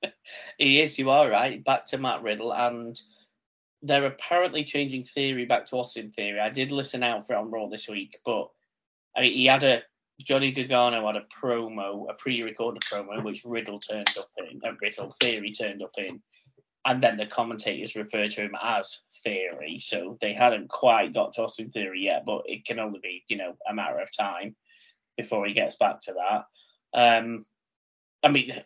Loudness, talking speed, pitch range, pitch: -26 LUFS, 195 wpm, 110-135 Hz, 120 Hz